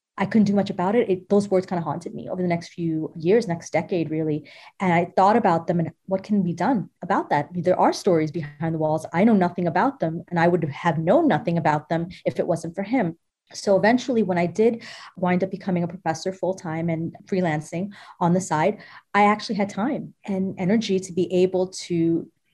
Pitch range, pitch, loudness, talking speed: 165-195 Hz, 180 Hz, -23 LUFS, 230 wpm